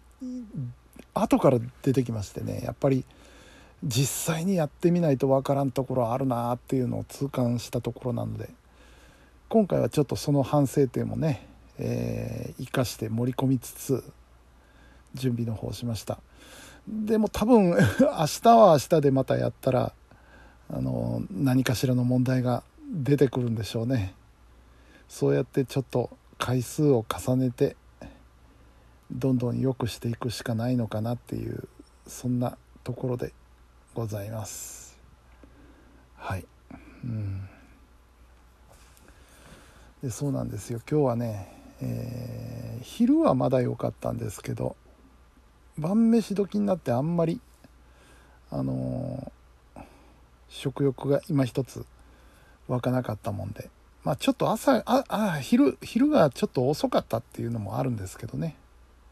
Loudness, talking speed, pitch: -27 LUFS, 265 characters per minute, 120 Hz